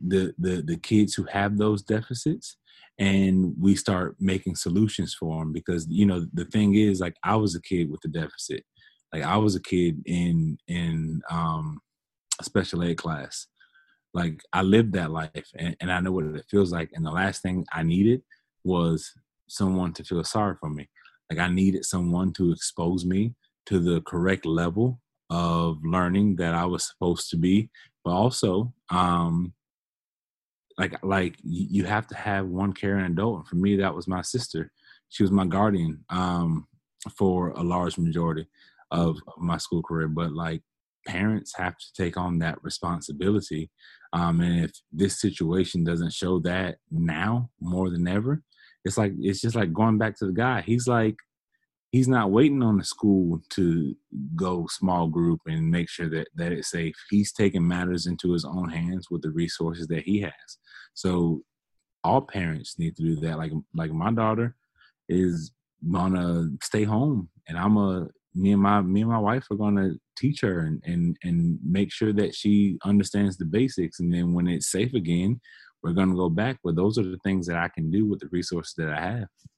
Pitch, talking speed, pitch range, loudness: 90 Hz, 185 wpm, 85-105 Hz, -26 LUFS